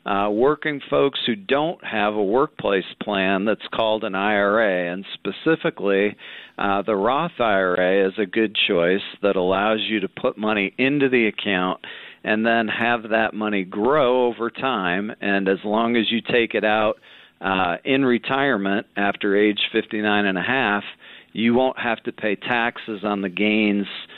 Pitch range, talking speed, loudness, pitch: 100-115 Hz, 165 wpm, -21 LUFS, 105 Hz